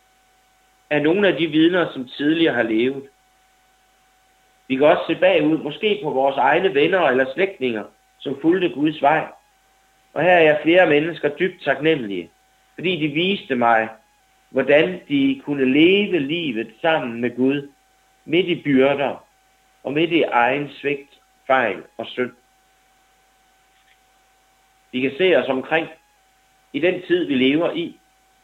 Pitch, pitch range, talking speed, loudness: 155 Hz, 135-185 Hz, 140 wpm, -19 LUFS